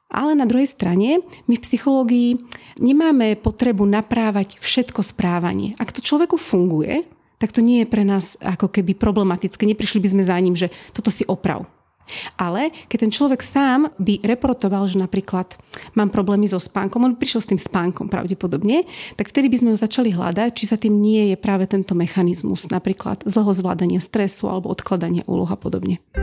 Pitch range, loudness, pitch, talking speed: 190-240 Hz, -19 LUFS, 210 Hz, 180 wpm